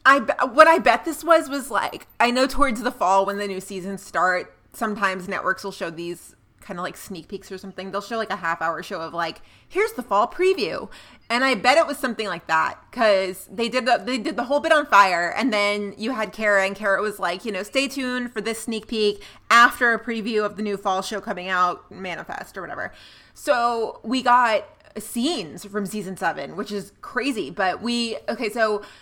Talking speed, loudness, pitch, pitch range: 220 wpm, -22 LUFS, 215 Hz, 195-255 Hz